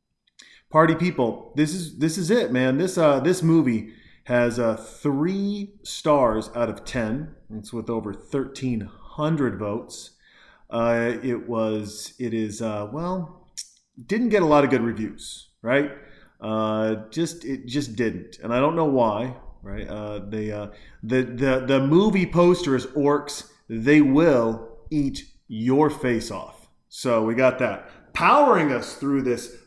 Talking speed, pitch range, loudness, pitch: 150 wpm, 110-150 Hz, -23 LUFS, 125 Hz